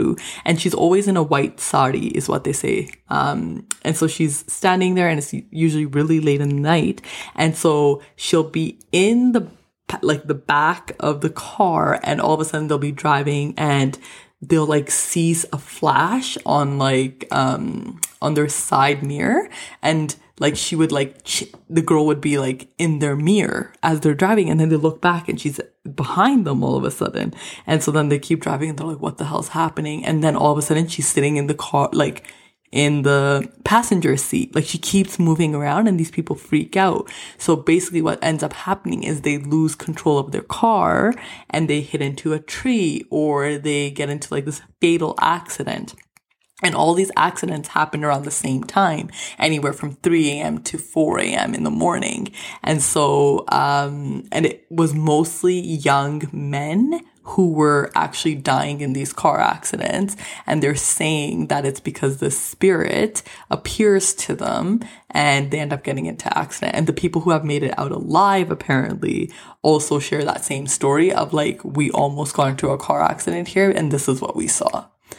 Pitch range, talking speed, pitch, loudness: 145-165 Hz, 190 wpm, 155 Hz, -19 LUFS